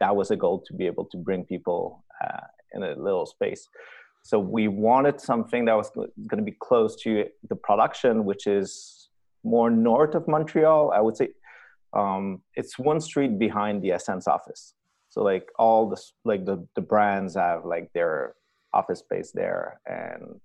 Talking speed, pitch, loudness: 175 wpm, 120 Hz, -25 LUFS